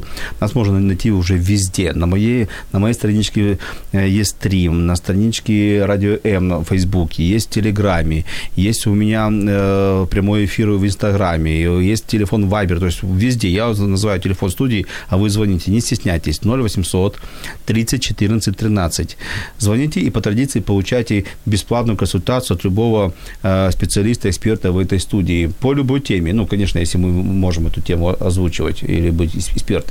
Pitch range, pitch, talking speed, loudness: 90-110 Hz, 100 Hz, 150 wpm, -17 LUFS